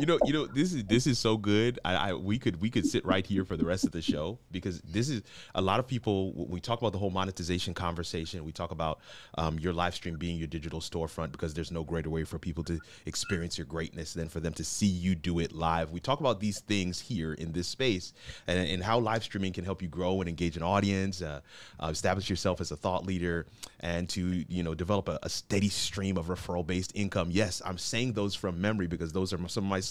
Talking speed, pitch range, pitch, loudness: 250 wpm, 85-100 Hz, 90 Hz, -32 LUFS